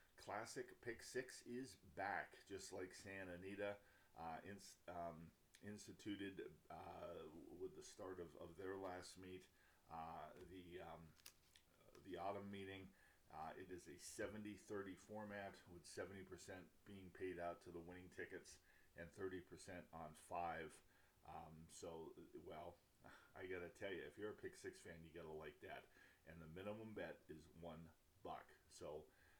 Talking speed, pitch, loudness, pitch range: 145 wpm, 95 Hz, -56 LUFS, 85-100 Hz